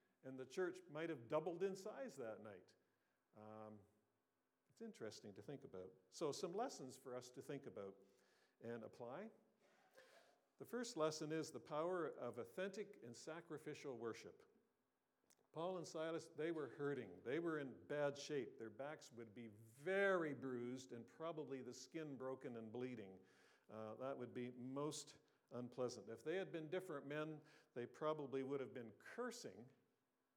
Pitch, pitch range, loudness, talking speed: 140 Hz, 120-160 Hz, -50 LUFS, 155 wpm